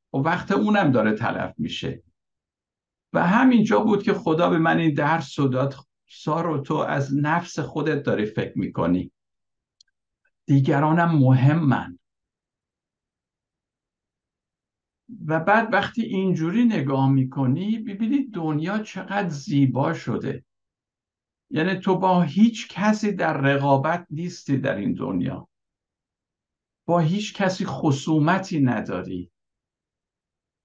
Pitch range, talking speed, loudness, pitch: 135-190 Hz, 110 wpm, -22 LUFS, 160 Hz